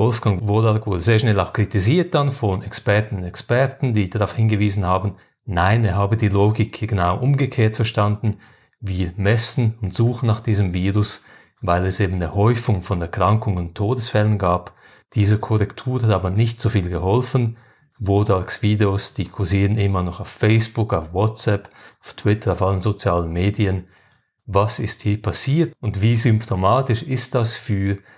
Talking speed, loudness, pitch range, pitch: 160 wpm, -19 LUFS, 100-115 Hz, 105 Hz